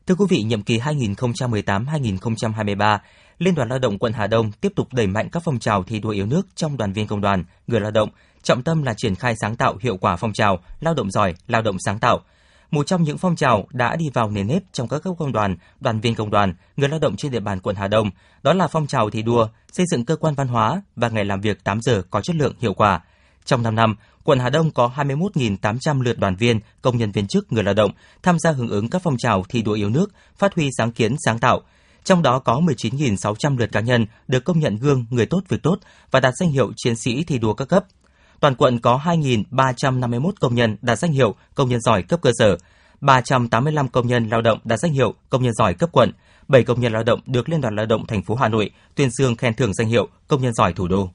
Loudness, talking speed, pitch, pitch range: -20 LUFS, 250 wpm, 120 Hz, 105-140 Hz